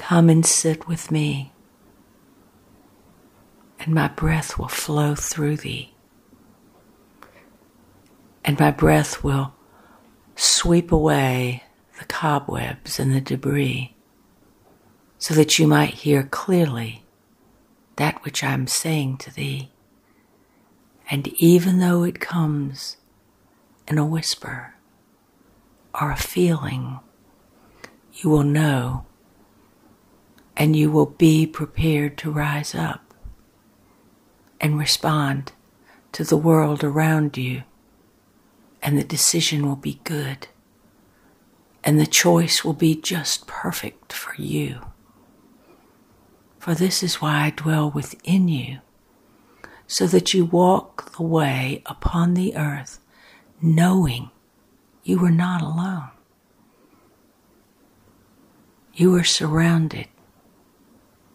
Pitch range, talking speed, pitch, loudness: 135-165 Hz, 105 wpm, 150 Hz, -20 LUFS